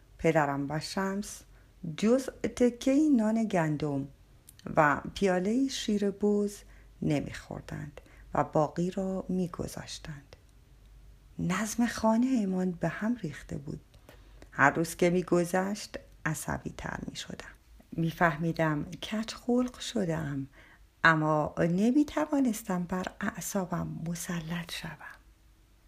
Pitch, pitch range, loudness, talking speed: 180 Hz, 155-215 Hz, -30 LUFS, 105 wpm